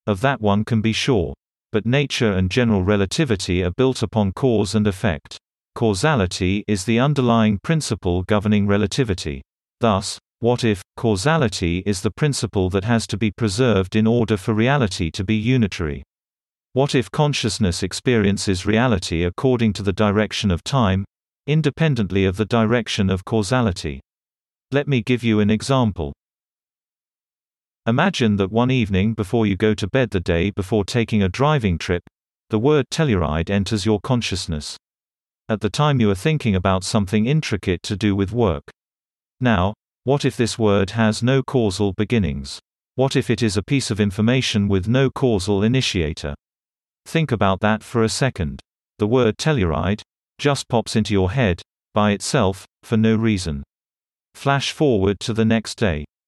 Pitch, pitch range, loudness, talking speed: 110 Hz, 100-120 Hz, -20 LUFS, 155 wpm